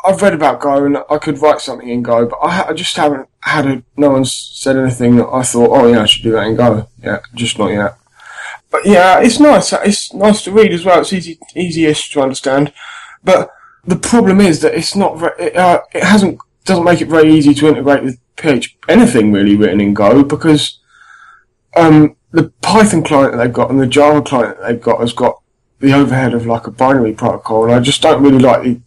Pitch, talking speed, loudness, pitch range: 140 Hz, 230 wpm, -11 LUFS, 120-165 Hz